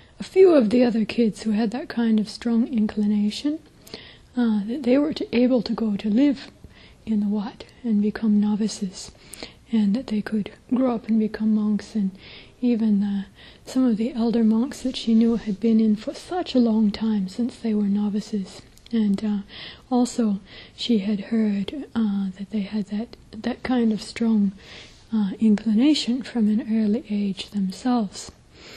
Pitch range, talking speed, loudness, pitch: 210-240 Hz, 175 wpm, -23 LUFS, 220 Hz